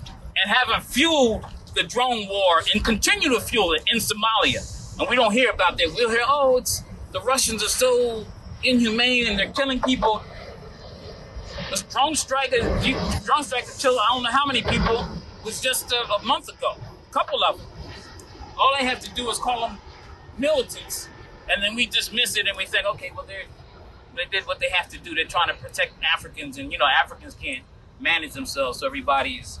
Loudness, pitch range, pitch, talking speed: -22 LUFS, 210-275 Hz, 245 Hz, 185 wpm